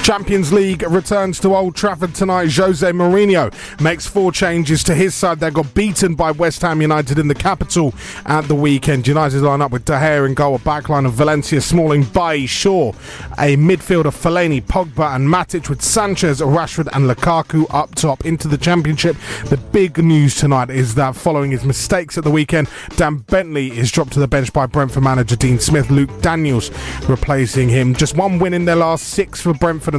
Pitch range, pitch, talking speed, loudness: 140-175 Hz, 155 Hz, 195 wpm, -15 LUFS